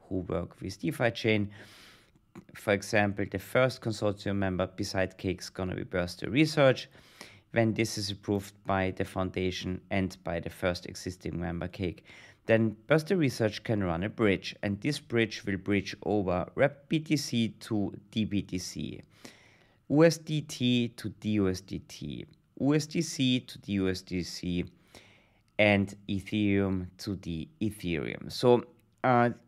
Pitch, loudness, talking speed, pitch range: 100 Hz, -30 LUFS, 130 wpm, 95-120 Hz